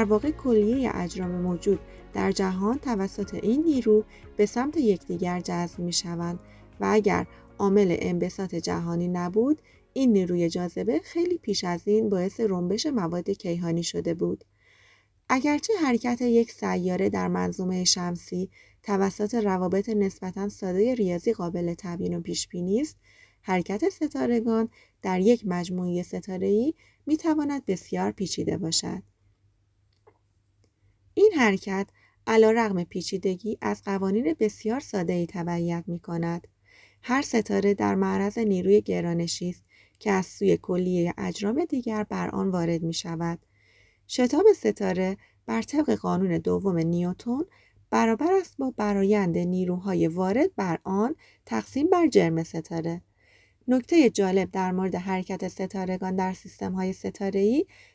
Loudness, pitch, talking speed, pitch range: -26 LUFS, 190 Hz, 130 wpm, 175-220 Hz